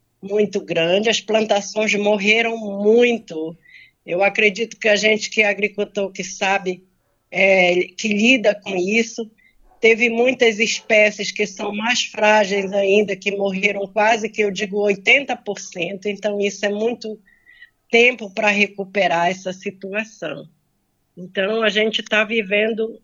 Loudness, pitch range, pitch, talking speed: -18 LUFS, 195-220 Hz, 210 Hz, 130 wpm